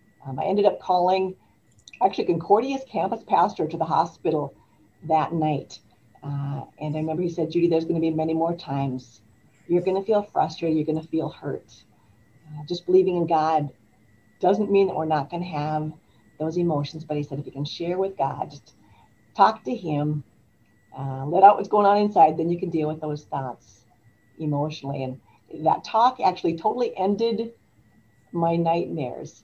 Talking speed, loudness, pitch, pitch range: 180 wpm, -24 LUFS, 155 Hz, 130-175 Hz